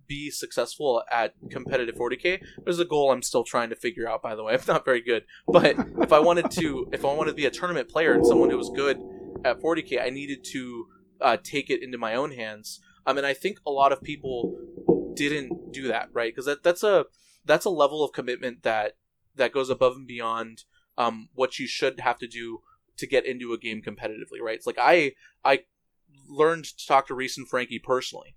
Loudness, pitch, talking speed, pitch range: -25 LUFS, 135 Hz, 220 wpm, 125-155 Hz